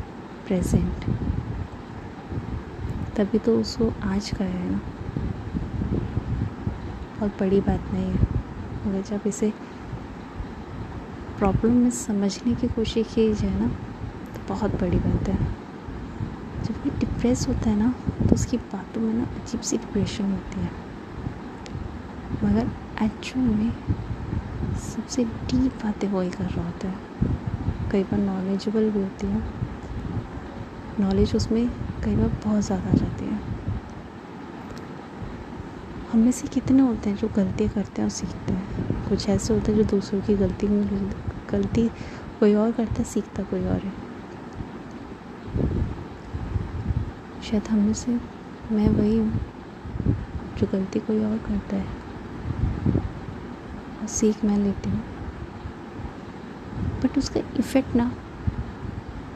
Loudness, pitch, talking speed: -26 LUFS, 205 Hz, 125 wpm